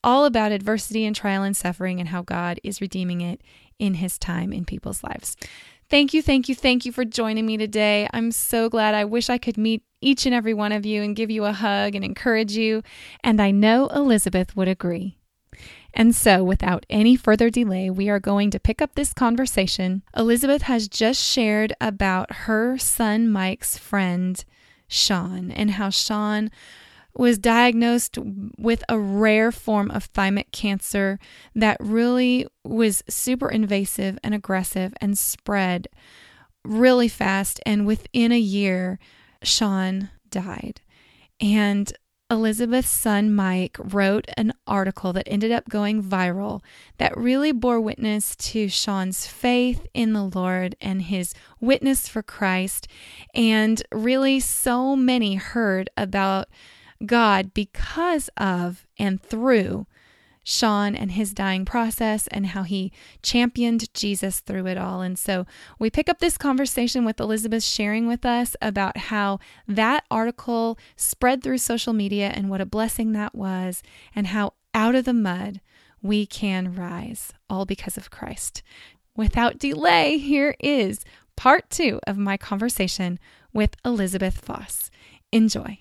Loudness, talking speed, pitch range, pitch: -22 LUFS, 150 wpm, 195-235 Hz, 215 Hz